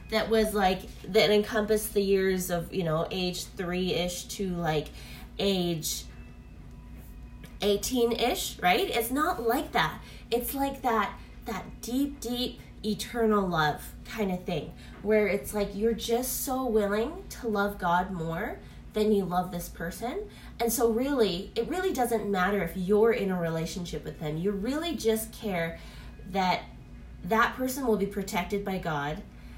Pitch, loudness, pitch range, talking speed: 205 Hz, -29 LUFS, 180-230 Hz, 150 wpm